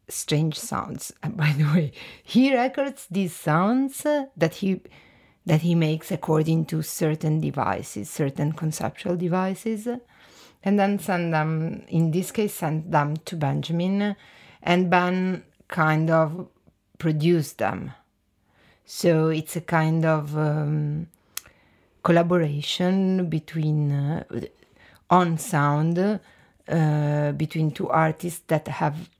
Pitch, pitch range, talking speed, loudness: 160 Hz, 155-185 Hz, 115 wpm, -24 LUFS